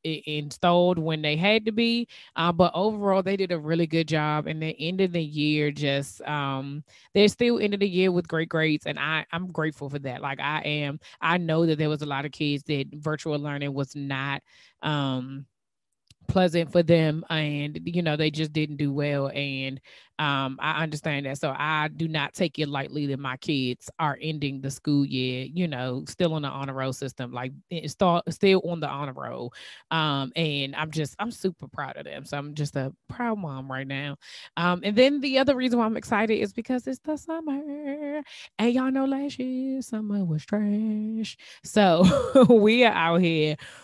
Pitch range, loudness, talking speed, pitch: 145-195 Hz, -26 LUFS, 200 wpm, 155 Hz